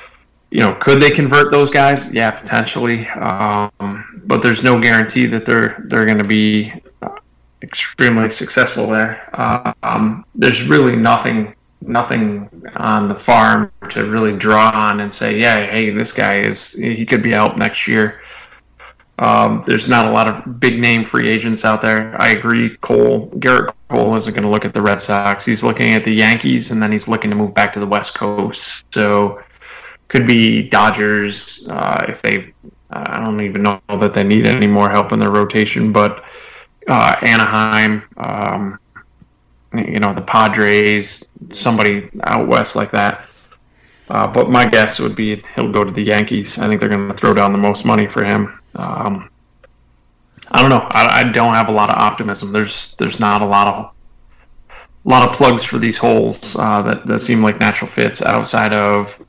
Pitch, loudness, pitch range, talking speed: 105 Hz, -14 LUFS, 105-110 Hz, 180 wpm